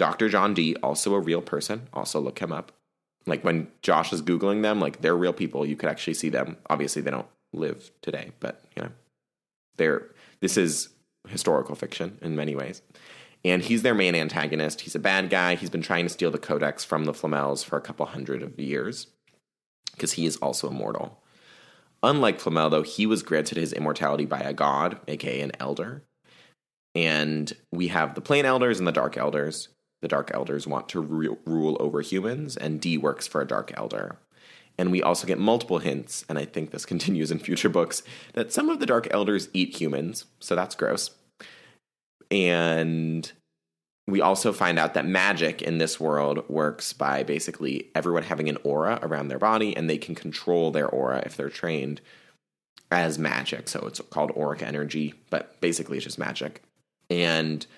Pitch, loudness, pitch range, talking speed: 80 Hz, -26 LUFS, 75-90 Hz, 185 wpm